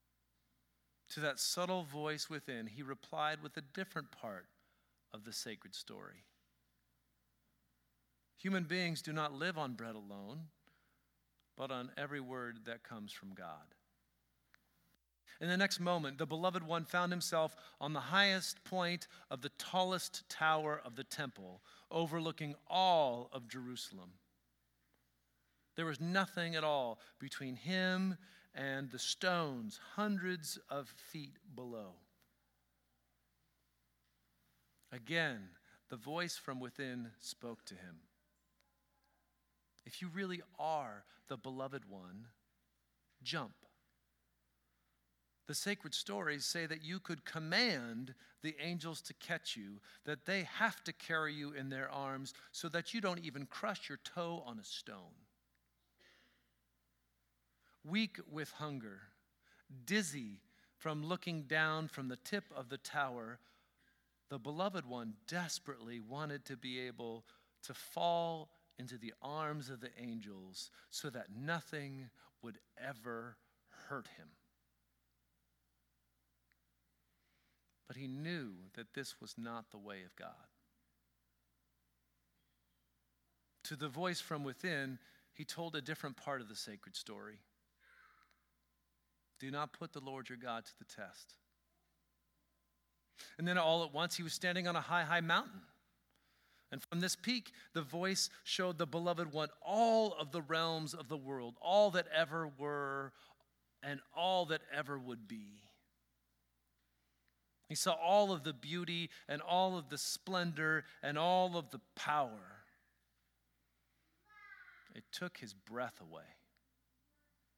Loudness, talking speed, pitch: -40 LUFS, 130 wpm, 135 Hz